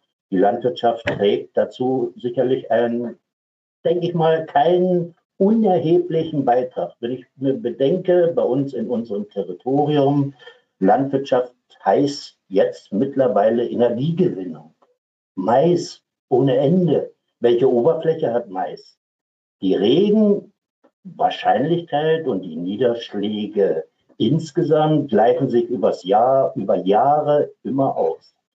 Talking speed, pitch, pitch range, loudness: 100 wpm, 145 Hz, 120-180 Hz, -19 LUFS